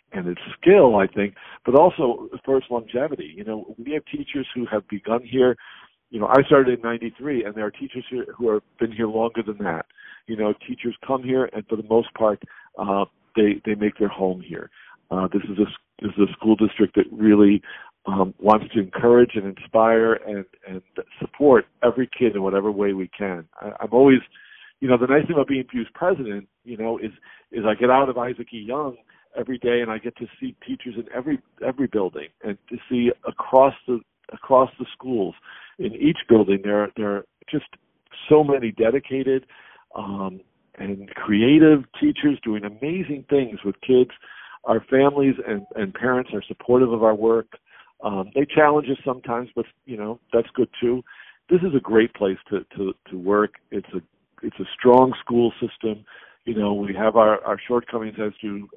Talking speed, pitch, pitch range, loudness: 195 wpm, 115 Hz, 105-130 Hz, -21 LUFS